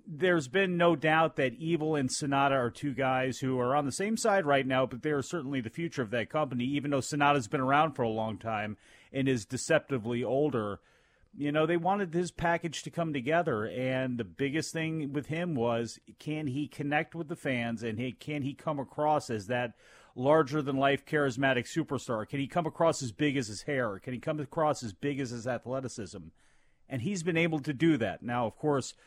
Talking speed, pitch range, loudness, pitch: 210 wpm, 125-155 Hz, -31 LUFS, 140 Hz